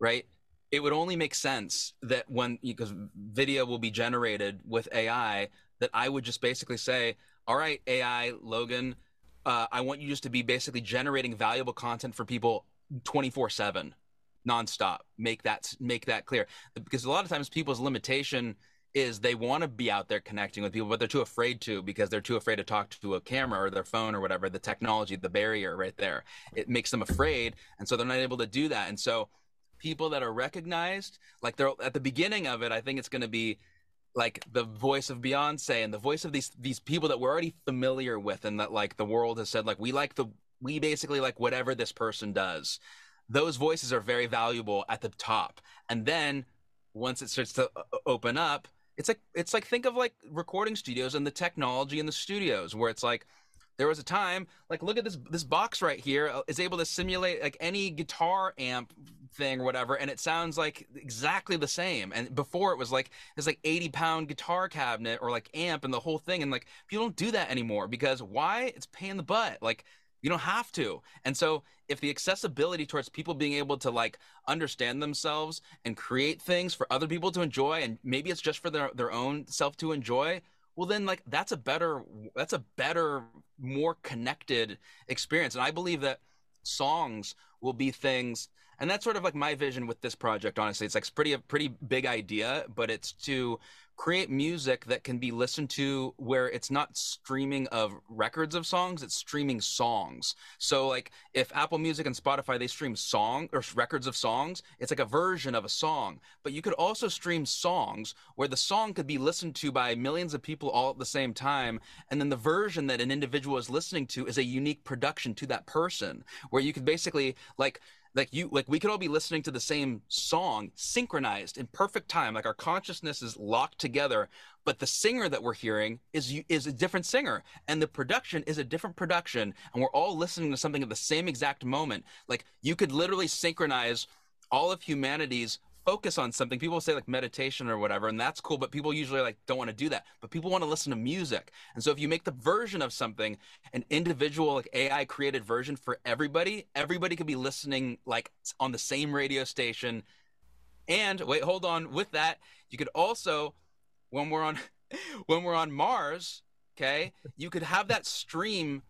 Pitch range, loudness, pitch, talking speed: 120-160 Hz, -31 LUFS, 140 Hz, 205 wpm